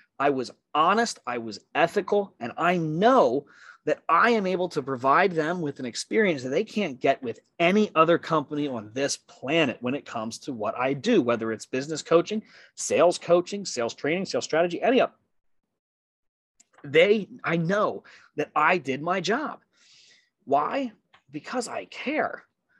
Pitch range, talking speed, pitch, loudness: 145-210 Hz, 165 wpm, 175 Hz, -25 LUFS